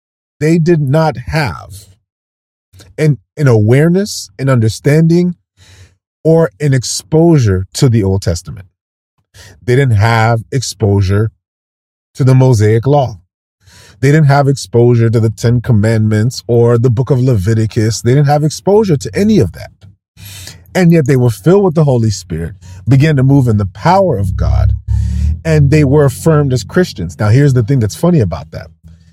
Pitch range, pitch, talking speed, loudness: 95-145 Hz, 115 Hz, 155 wpm, -11 LUFS